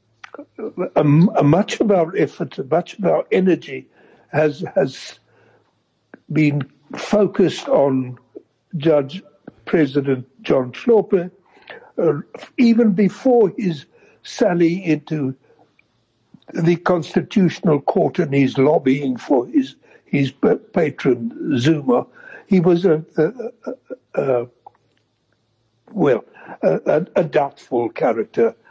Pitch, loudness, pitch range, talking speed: 155 Hz, -18 LUFS, 135-185 Hz, 95 wpm